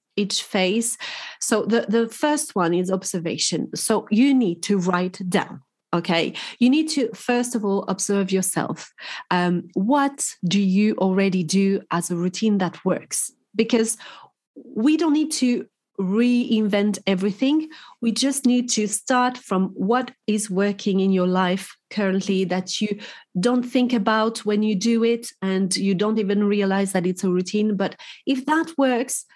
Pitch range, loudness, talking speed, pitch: 190-245 Hz, -22 LUFS, 155 wpm, 210 Hz